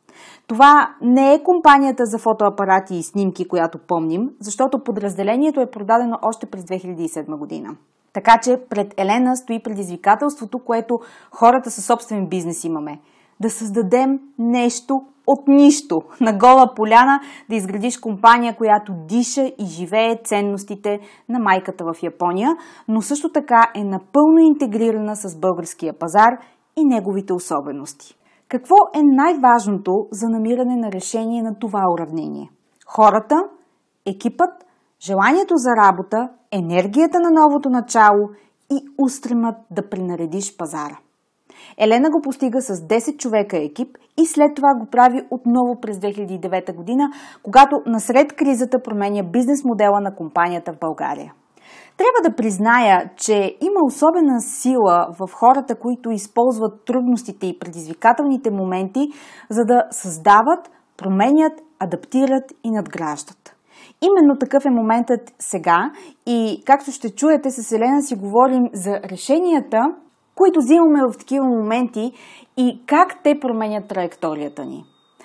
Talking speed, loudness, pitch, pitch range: 130 wpm, -17 LUFS, 230 Hz, 200-275 Hz